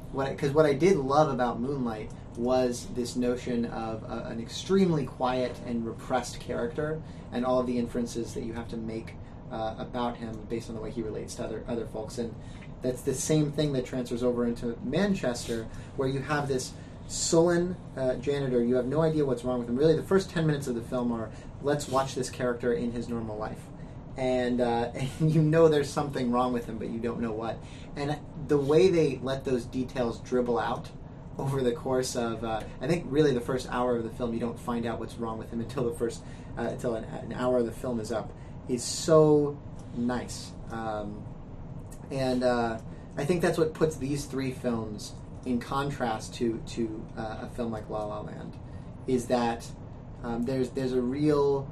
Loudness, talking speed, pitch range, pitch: -29 LUFS, 200 wpm, 115-140 Hz, 125 Hz